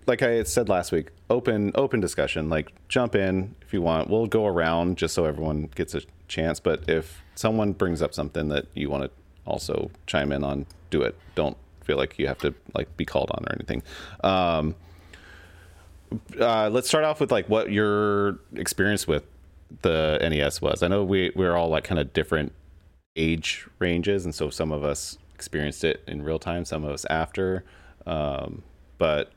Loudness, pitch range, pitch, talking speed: -26 LUFS, 75-95 Hz, 80 Hz, 190 wpm